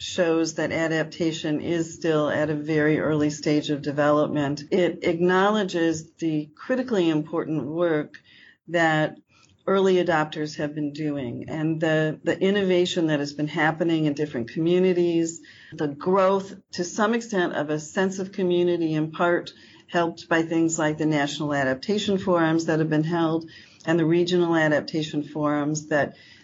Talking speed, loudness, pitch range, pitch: 150 wpm, -24 LUFS, 150-175 Hz, 160 Hz